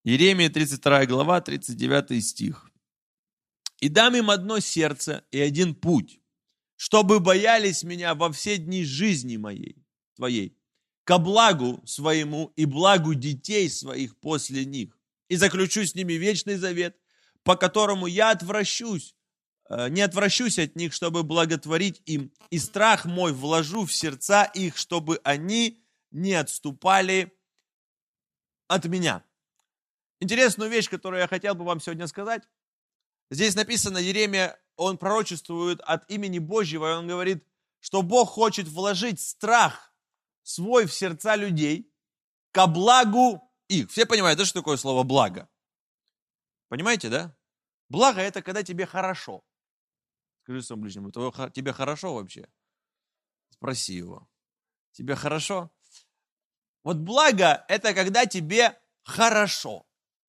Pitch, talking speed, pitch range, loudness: 185 Hz, 120 wpm, 155-205 Hz, -24 LUFS